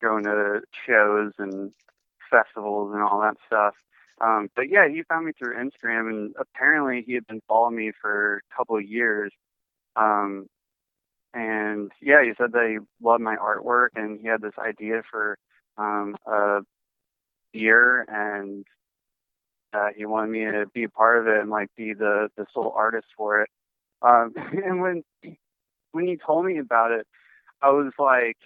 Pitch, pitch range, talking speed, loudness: 110 Hz, 105-115 Hz, 170 wpm, -23 LUFS